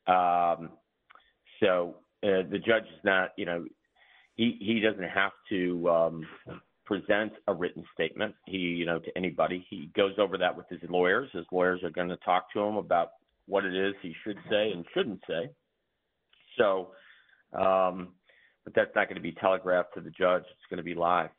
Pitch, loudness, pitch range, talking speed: 90 Hz, -29 LUFS, 85-95 Hz, 185 wpm